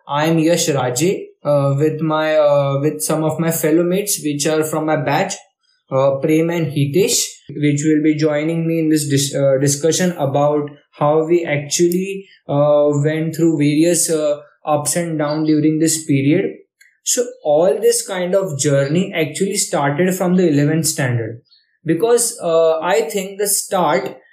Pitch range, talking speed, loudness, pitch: 145-175 Hz, 165 wpm, -16 LUFS, 155 Hz